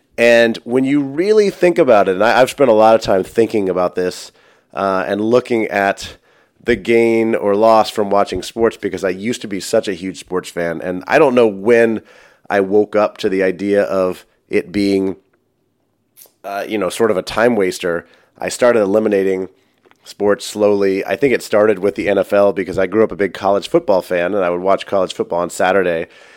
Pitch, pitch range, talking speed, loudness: 100 Hz, 95-115 Hz, 205 wpm, -15 LUFS